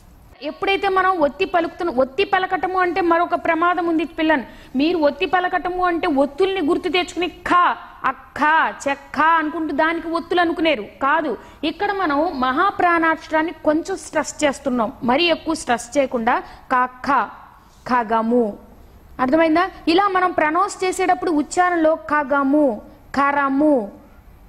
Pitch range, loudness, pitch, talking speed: 290-360 Hz, -19 LUFS, 325 Hz, 115 wpm